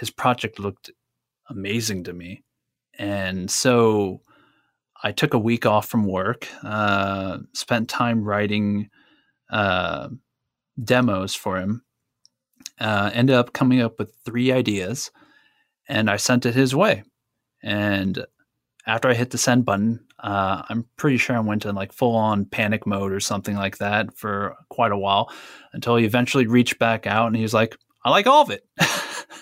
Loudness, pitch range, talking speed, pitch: -22 LUFS, 100-120 Hz, 160 wpm, 110 Hz